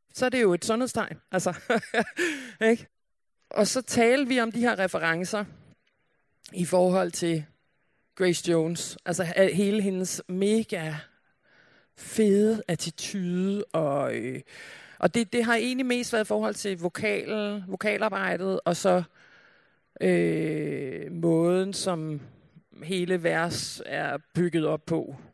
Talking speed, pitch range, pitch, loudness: 120 wpm, 170-215 Hz, 190 Hz, -27 LUFS